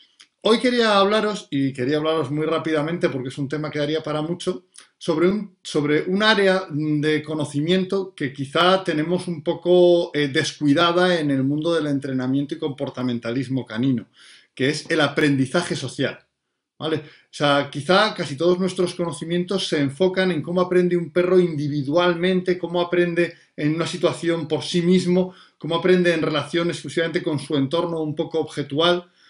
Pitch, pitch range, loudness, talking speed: 165 Hz, 150-180 Hz, -21 LUFS, 160 wpm